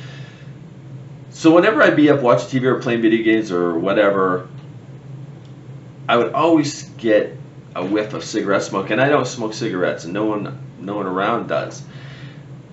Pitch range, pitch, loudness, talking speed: 110-145 Hz, 135 Hz, -18 LUFS, 160 wpm